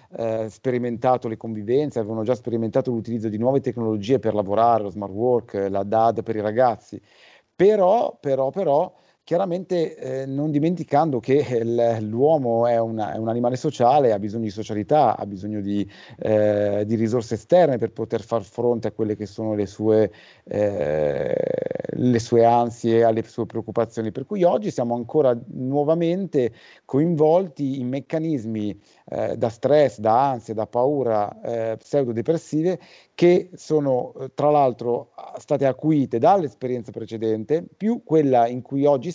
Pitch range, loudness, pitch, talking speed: 110-145 Hz, -22 LUFS, 120 Hz, 145 wpm